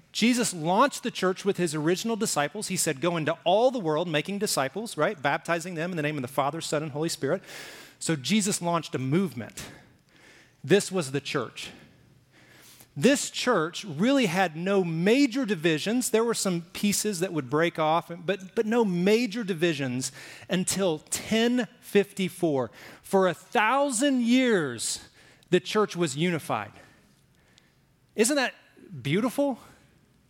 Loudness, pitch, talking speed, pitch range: -26 LUFS, 185 Hz, 145 wpm, 155-215 Hz